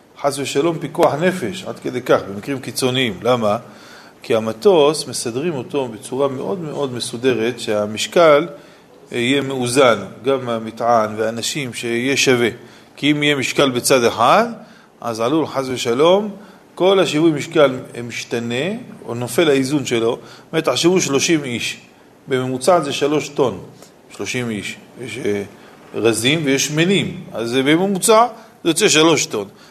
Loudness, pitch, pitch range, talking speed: -17 LUFS, 135 Hz, 120-160 Hz, 130 wpm